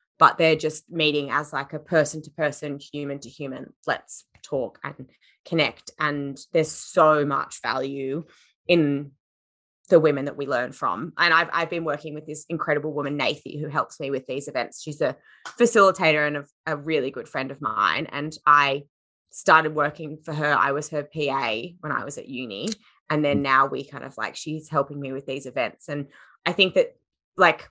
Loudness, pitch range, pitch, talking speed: -24 LUFS, 140-155 Hz, 150 Hz, 195 wpm